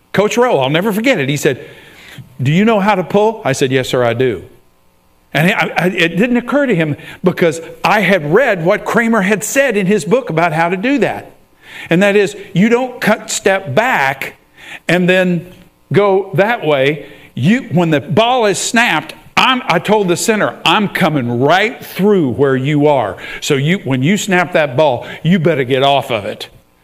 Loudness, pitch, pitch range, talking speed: -13 LUFS, 180 Hz, 145-210 Hz, 190 wpm